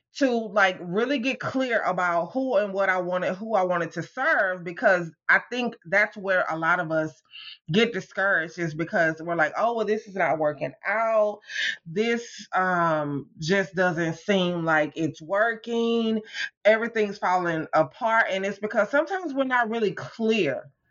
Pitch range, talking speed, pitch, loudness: 170-225 Hz, 165 wpm, 195 Hz, -25 LUFS